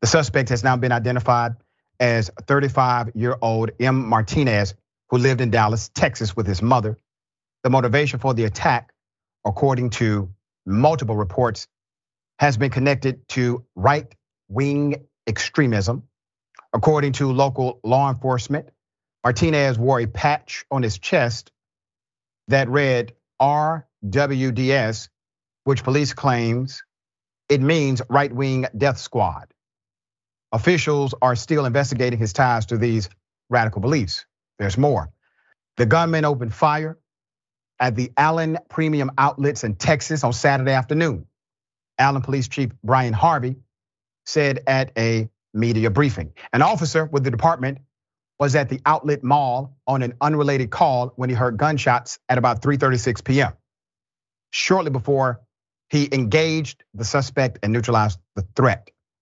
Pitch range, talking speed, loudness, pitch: 115-140 Hz, 130 wpm, -20 LUFS, 130 Hz